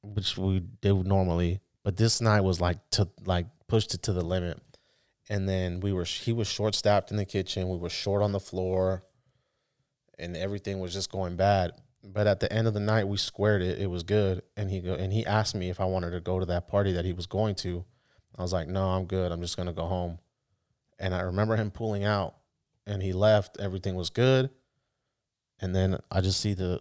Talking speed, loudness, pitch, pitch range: 225 wpm, -29 LUFS, 95 Hz, 90-105 Hz